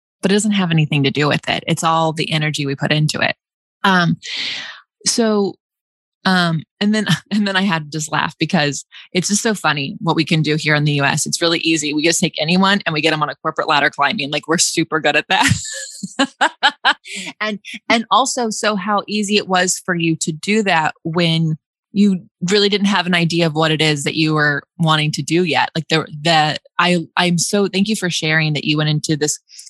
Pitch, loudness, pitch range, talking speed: 170 Hz, -16 LUFS, 155-200 Hz, 220 wpm